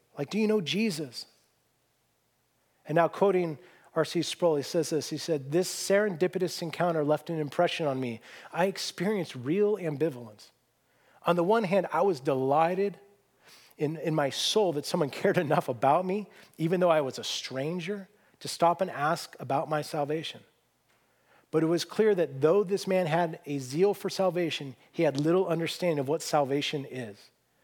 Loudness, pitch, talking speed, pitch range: -28 LUFS, 165 Hz, 170 wpm, 150-185 Hz